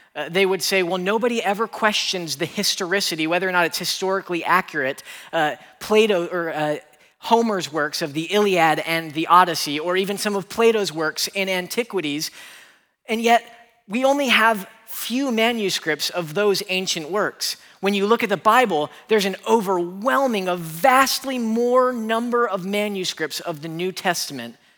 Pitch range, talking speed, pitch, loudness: 175-225 Hz, 160 wpm, 195 Hz, -21 LUFS